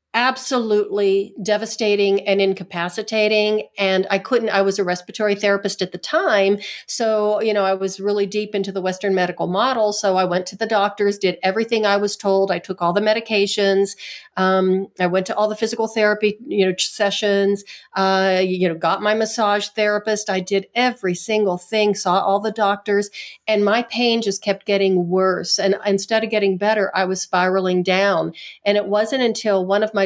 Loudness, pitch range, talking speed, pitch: -19 LUFS, 190-215 Hz, 185 wpm, 200 Hz